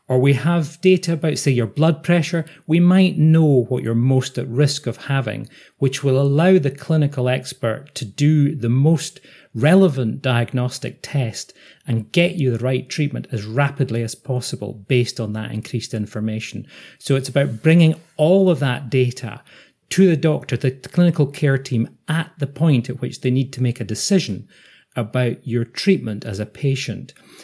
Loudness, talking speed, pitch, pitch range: -19 LUFS, 175 wpm, 135 Hz, 120-155 Hz